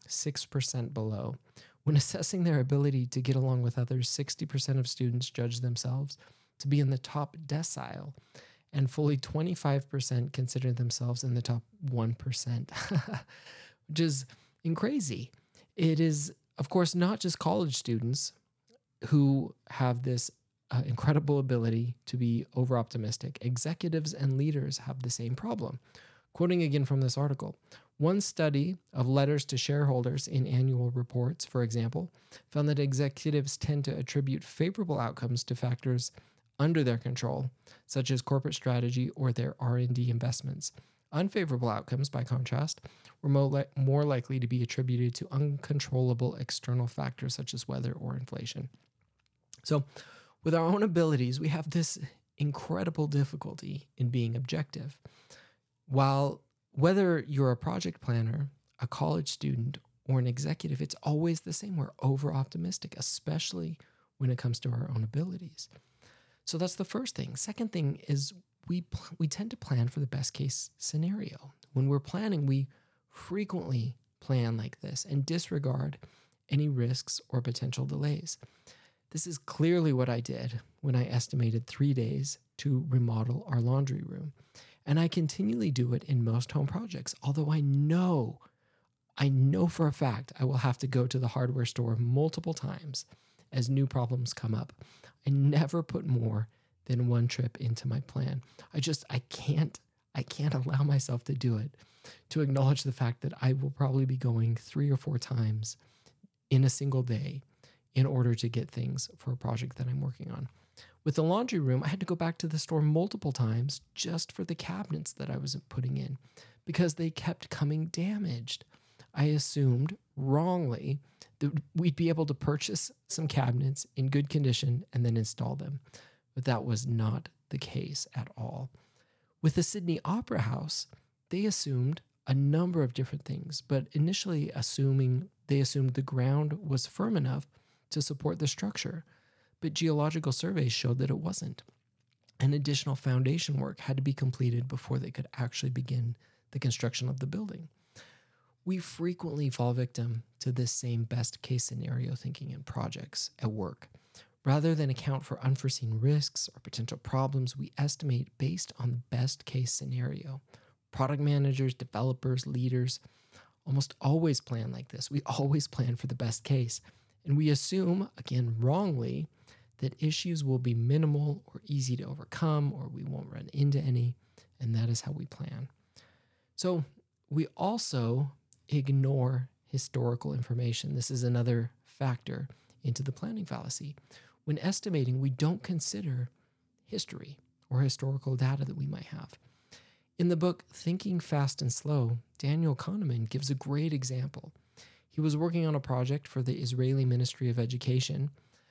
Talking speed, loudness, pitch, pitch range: 155 wpm, -32 LUFS, 135 Hz, 125-150 Hz